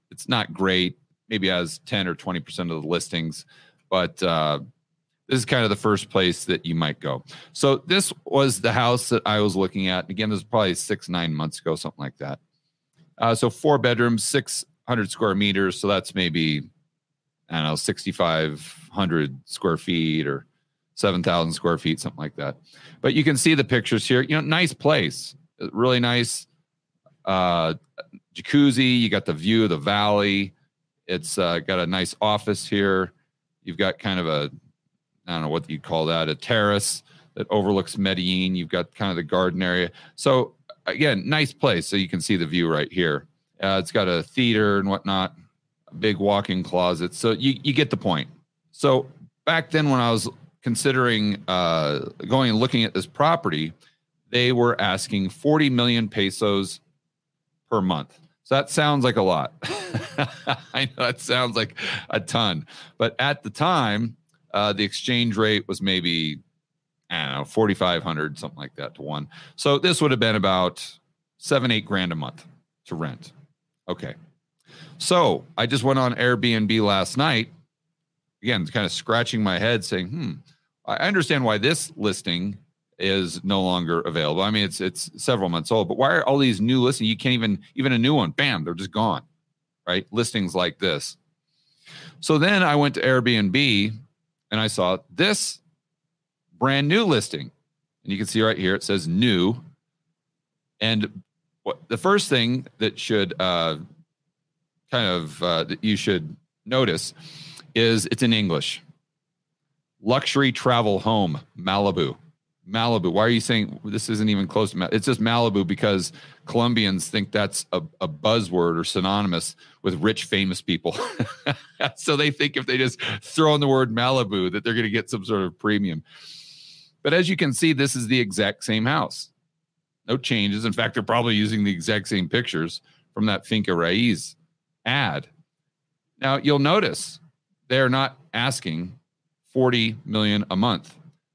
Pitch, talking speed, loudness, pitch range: 120 Hz, 170 wpm, -23 LUFS, 95-155 Hz